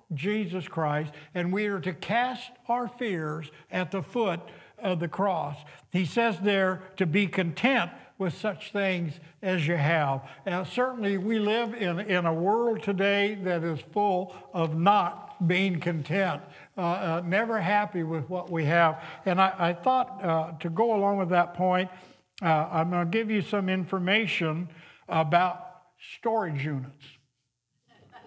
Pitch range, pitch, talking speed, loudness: 165-205 Hz, 185 Hz, 155 wpm, -28 LUFS